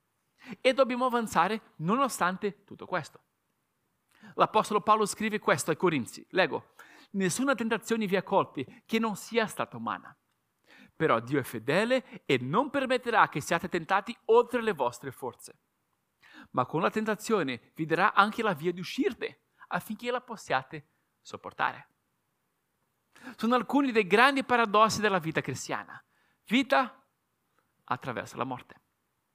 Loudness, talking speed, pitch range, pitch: -29 LUFS, 130 wpm, 175-240 Hz, 215 Hz